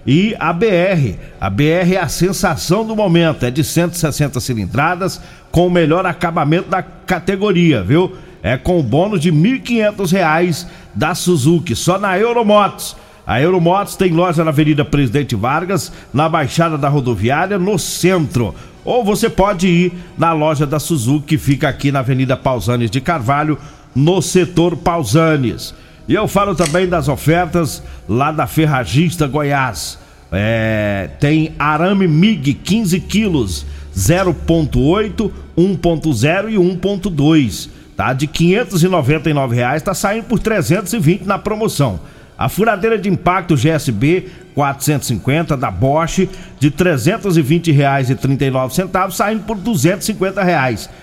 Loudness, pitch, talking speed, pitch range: -15 LUFS, 165 Hz, 135 wpm, 140-185 Hz